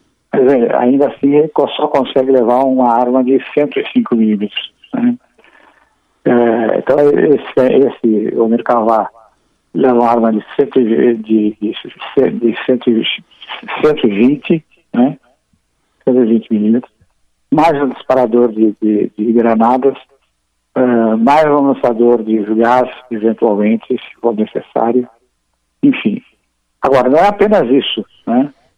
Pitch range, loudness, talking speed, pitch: 110-135 Hz, -13 LUFS, 115 wpm, 120 Hz